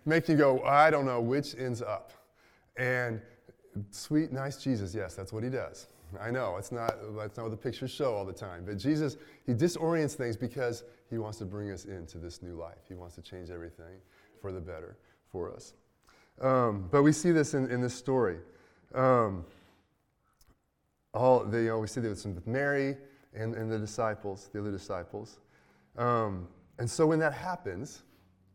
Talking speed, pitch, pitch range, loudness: 180 wpm, 115 Hz, 95-130 Hz, -31 LUFS